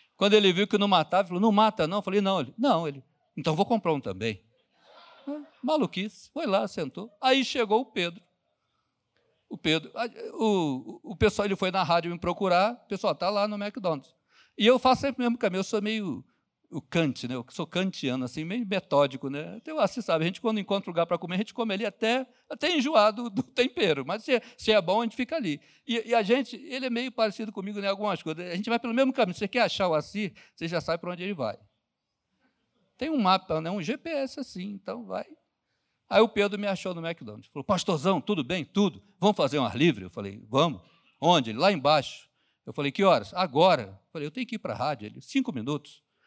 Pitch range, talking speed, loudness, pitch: 165-235 Hz, 235 wpm, -27 LUFS, 200 Hz